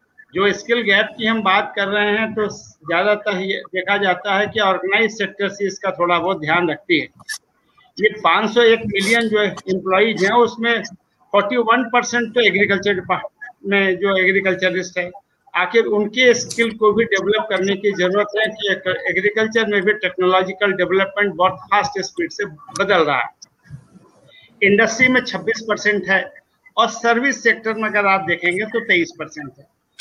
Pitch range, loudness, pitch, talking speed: 190-225 Hz, -17 LUFS, 205 Hz, 155 wpm